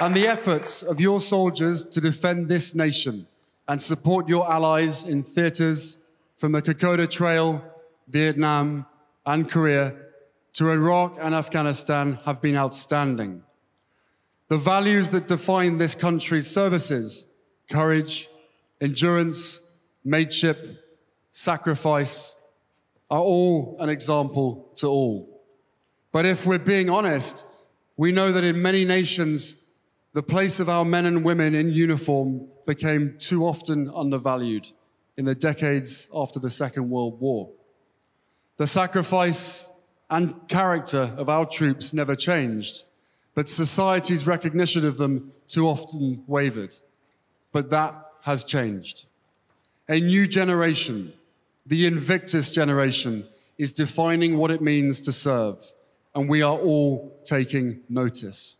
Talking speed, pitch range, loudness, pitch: 120 wpm, 140-170 Hz, -23 LUFS, 155 Hz